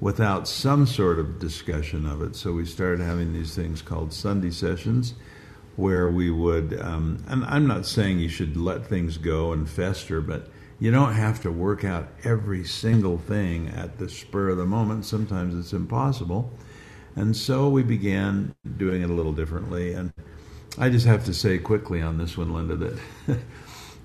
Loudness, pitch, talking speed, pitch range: -25 LUFS, 95 Hz, 175 wpm, 85-110 Hz